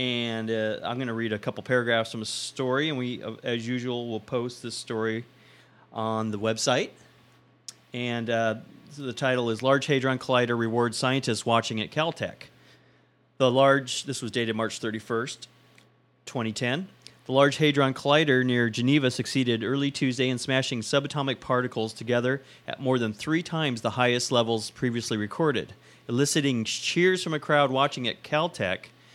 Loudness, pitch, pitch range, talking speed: -26 LUFS, 125 Hz, 115-135 Hz, 160 wpm